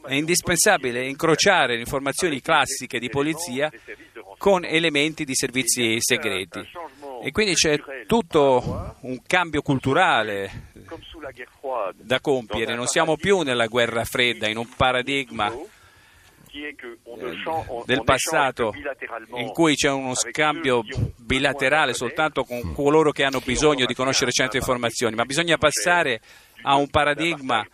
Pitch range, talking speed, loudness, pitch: 120-155 Hz, 120 wpm, -21 LUFS, 135 Hz